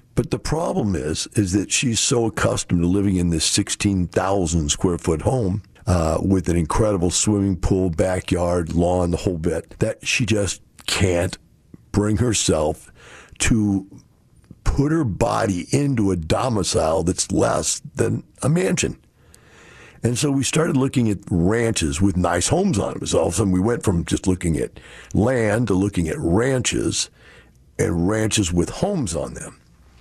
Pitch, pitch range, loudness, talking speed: 95 Hz, 90-110 Hz, -21 LUFS, 160 wpm